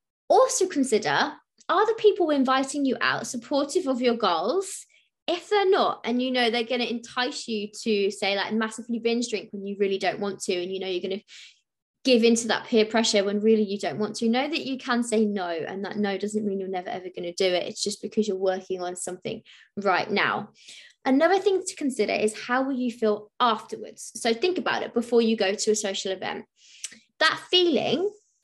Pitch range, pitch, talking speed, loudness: 205-265 Hz, 225 Hz, 215 wpm, -25 LUFS